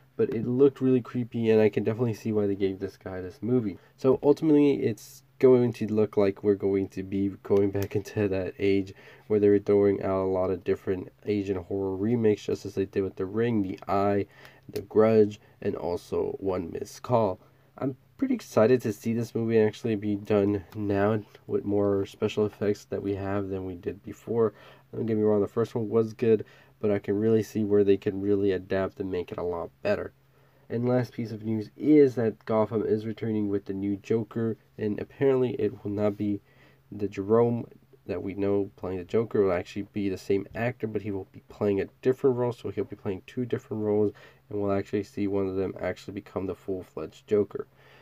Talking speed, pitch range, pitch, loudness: 215 wpm, 100-115 Hz, 105 Hz, -27 LUFS